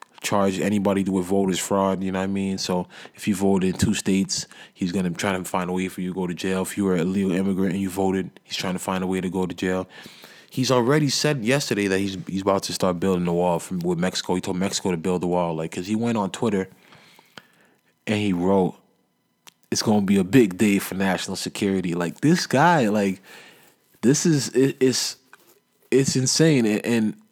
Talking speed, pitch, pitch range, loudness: 225 wpm, 95 Hz, 95-105 Hz, -23 LUFS